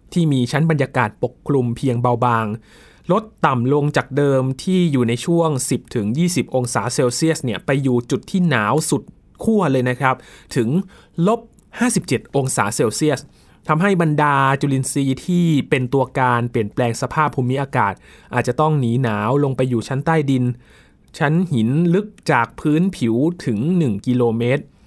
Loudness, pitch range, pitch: -19 LUFS, 125-160 Hz, 135 Hz